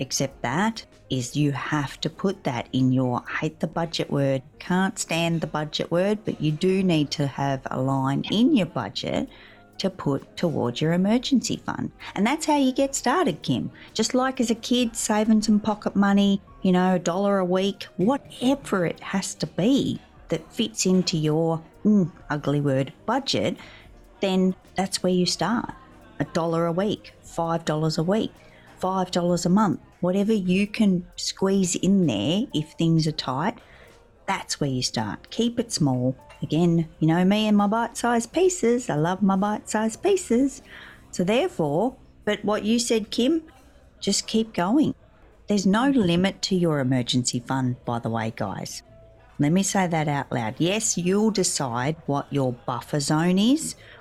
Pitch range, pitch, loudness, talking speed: 150-215 Hz, 180 Hz, -24 LUFS, 175 wpm